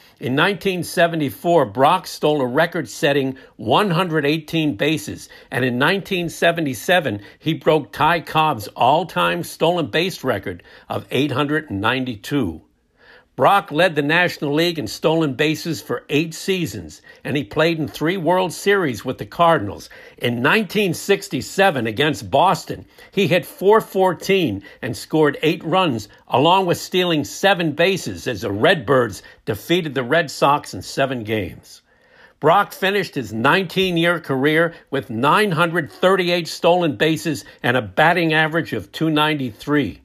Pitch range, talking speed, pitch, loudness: 135-175 Hz, 130 wpm, 155 Hz, -19 LUFS